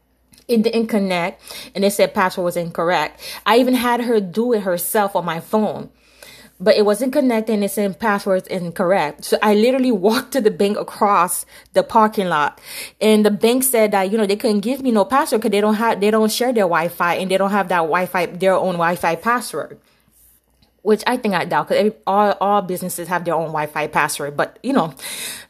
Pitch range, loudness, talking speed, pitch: 180-225 Hz, -18 LUFS, 215 wpm, 205 Hz